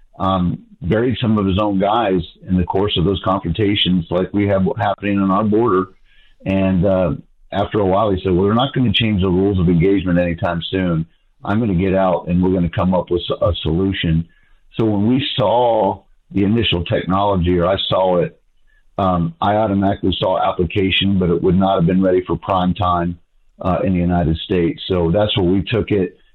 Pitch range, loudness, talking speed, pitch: 90-100 Hz, -17 LUFS, 205 wpm, 95 Hz